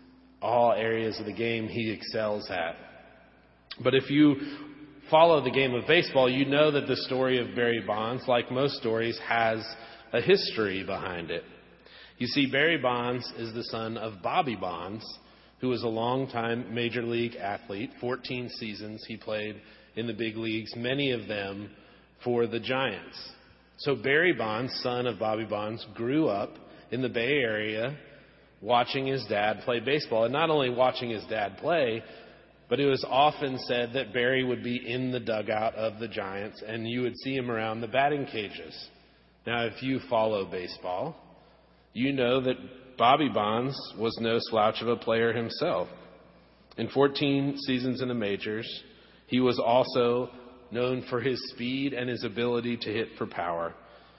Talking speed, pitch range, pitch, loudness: 165 wpm, 110-130 Hz, 120 Hz, -28 LUFS